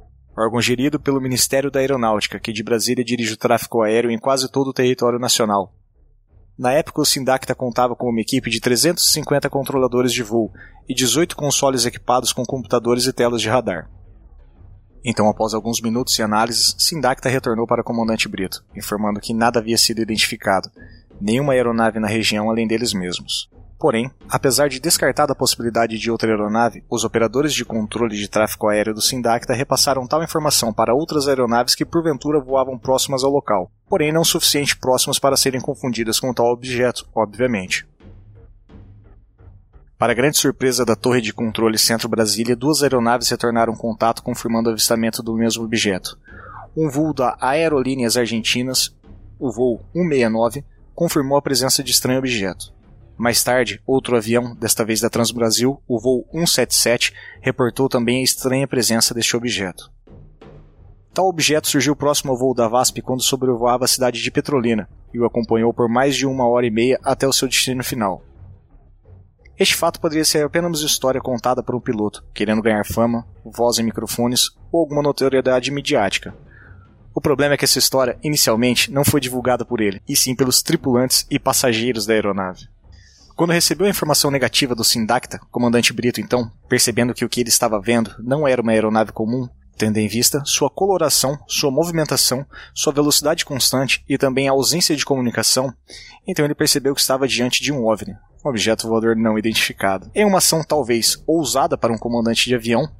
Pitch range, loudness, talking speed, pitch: 110-135 Hz, -18 LUFS, 170 wpm, 120 Hz